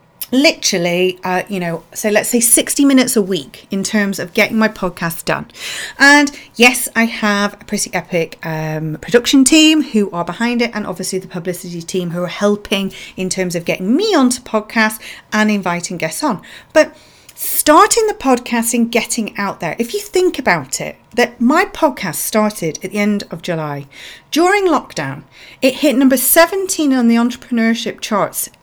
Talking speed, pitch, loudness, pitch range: 175 wpm, 215 Hz, -15 LUFS, 185-260 Hz